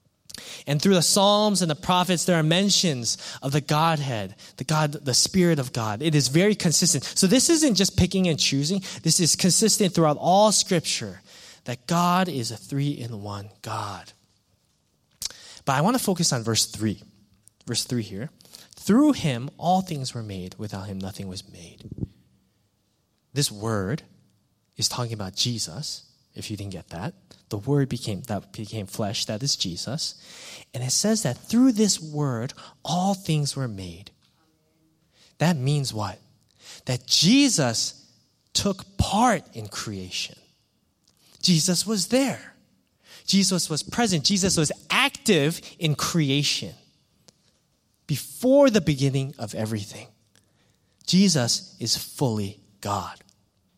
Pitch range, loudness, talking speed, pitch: 110-175 Hz, -23 LUFS, 140 wpm, 140 Hz